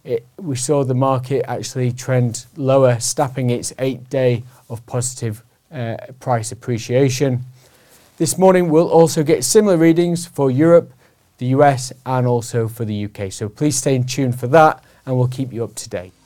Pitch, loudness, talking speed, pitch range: 130 Hz, -17 LUFS, 175 wpm, 120-145 Hz